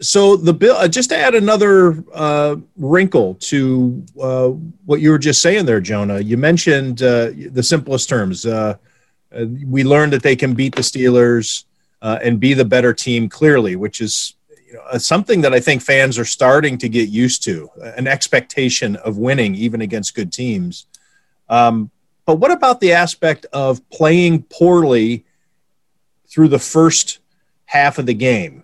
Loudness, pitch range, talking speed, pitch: -14 LUFS, 120-160 Hz, 170 wpm, 135 Hz